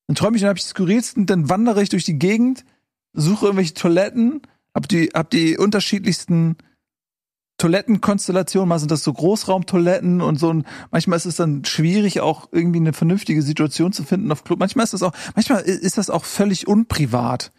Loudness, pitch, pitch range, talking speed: -18 LUFS, 185 Hz, 165-205 Hz, 185 wpm